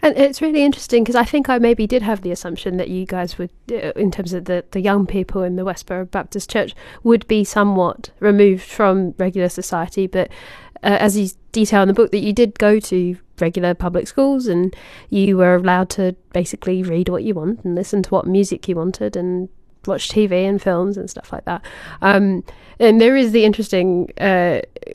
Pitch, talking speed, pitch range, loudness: 195 Hz, 205 wpm, 180-215 Hz, -17 LUFS